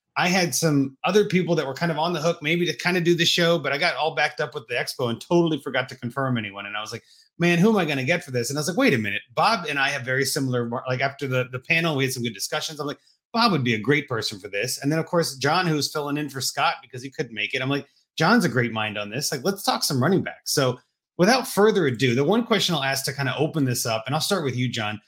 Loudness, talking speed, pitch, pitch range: -23 LUFS, 310 wpm, 150 Hz, 130-170 Hz